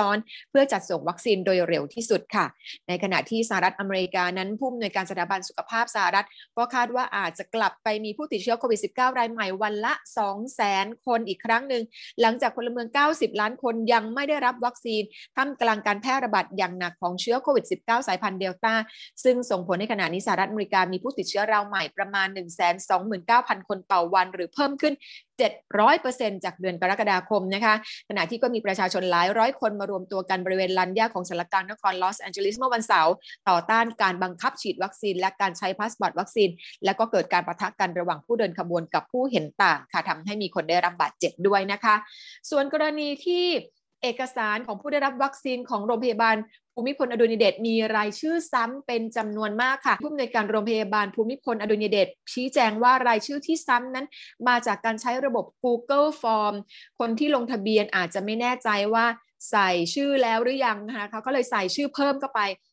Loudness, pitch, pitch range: -25 LUFS, 220 Hz, 195-245 Hz